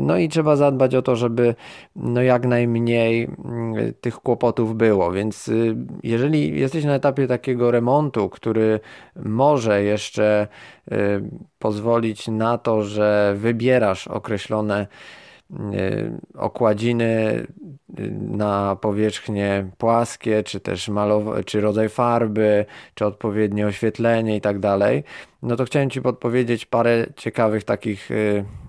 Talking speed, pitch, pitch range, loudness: 110 wpm, 110 Hz, 105-120 Hz, -21 LUFS